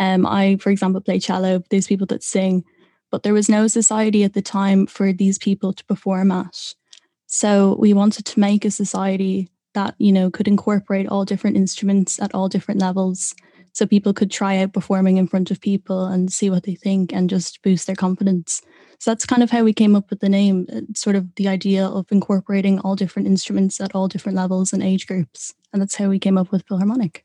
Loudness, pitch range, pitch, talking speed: -19 LUFS, 190-205 Hz, 195 Hz, 215 wpm